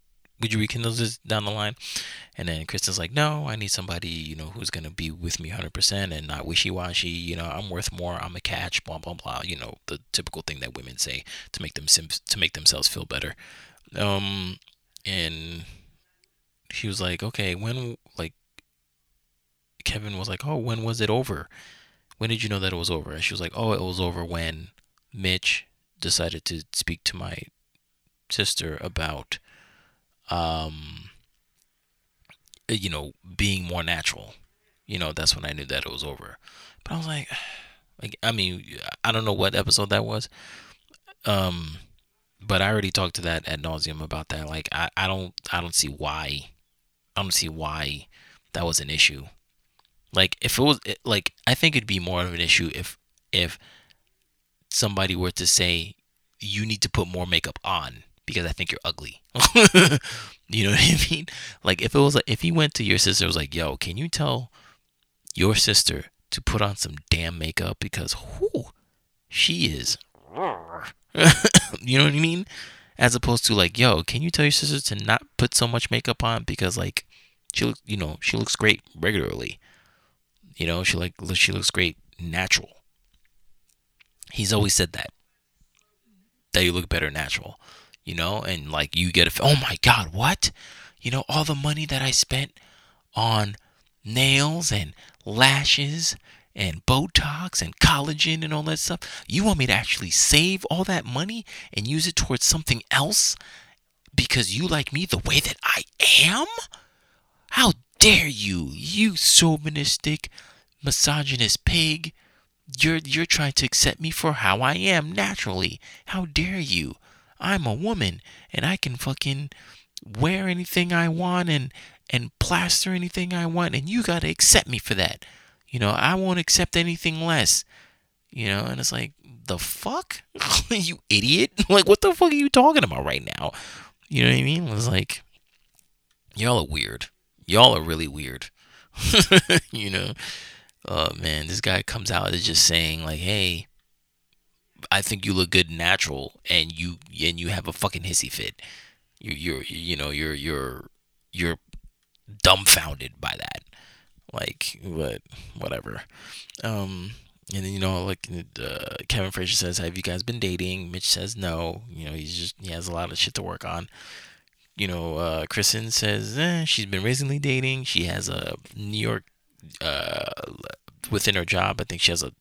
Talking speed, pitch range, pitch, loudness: 175 wpm, 85-130 Hz, 95 Hz, -22 LUFS